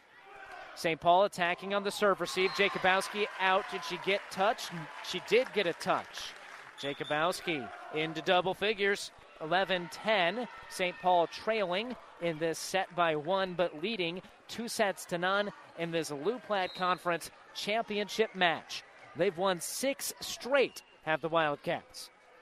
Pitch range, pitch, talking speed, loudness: 170-205 Hz, 185 Hz, 135 wpm, -32 LUFS